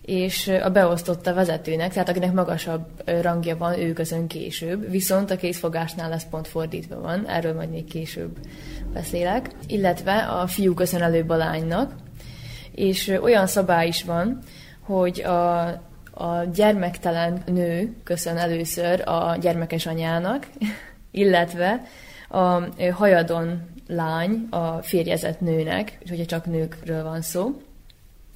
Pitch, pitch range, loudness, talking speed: 175 Hz, 165-185 Hz, -23 LUFS, 125 wpm